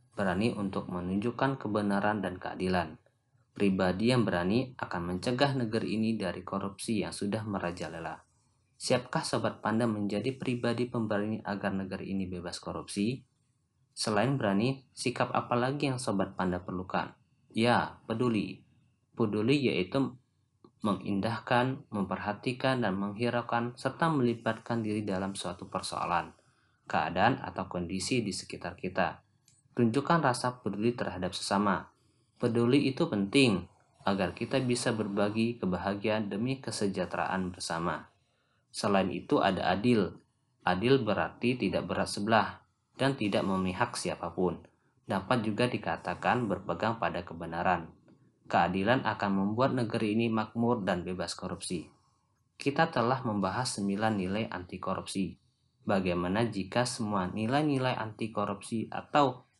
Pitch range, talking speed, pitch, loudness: 95-125 Hz, 115 wpm, 110 Hz, -31 LUFS